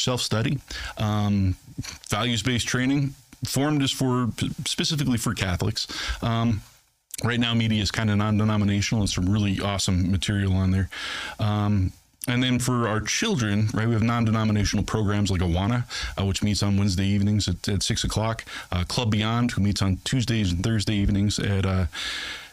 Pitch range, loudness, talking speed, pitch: 100-120 Hz, -24 LUFS, 160 wpm, 105 Hz